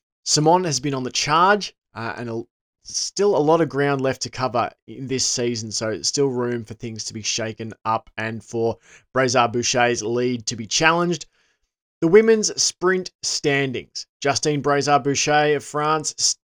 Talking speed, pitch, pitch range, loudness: 170 wpm, 130 Hz, 115-150 Hz, -21 LUFS